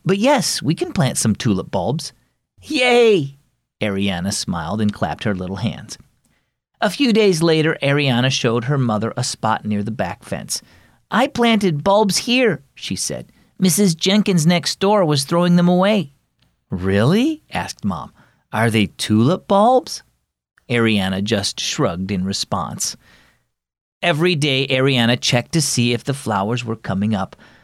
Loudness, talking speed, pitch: -18 LUFS, 150 wpm, 135 Hz